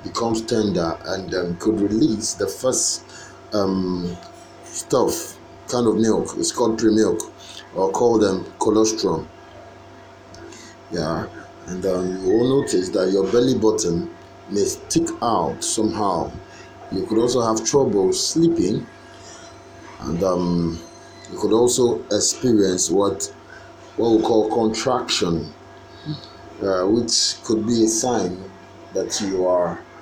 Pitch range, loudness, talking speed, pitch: 95-120 Hz, -20 LUFS, 125 wpm, 110 Hz